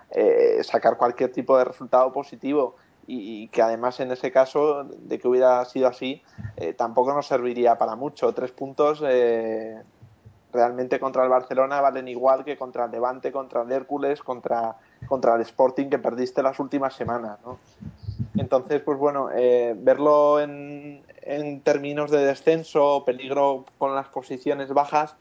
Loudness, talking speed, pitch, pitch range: -23 LUFS, 160 wpm, 130 Hz, 125-145 Hz